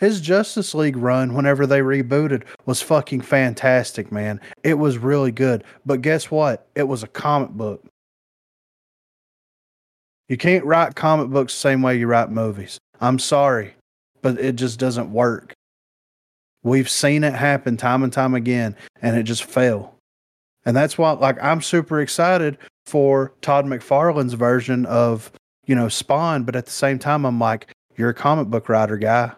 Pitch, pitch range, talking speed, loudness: 130 Hz, 120-145 Hz, 165 wpm, -19 LUFS